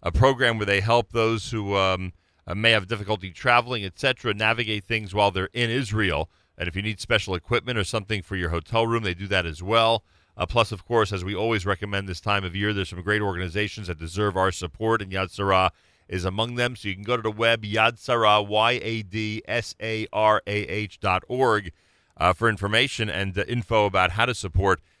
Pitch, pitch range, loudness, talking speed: 105 Hz, 95-115 Hz, -24 LUFS, 220 wpm